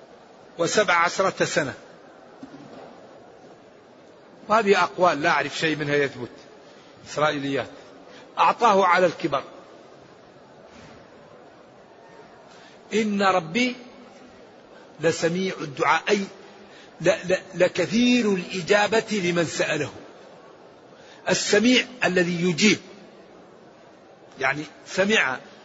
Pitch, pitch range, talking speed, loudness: 180 Hz, 160-205 Hz, 65 wpm, -22 LUFS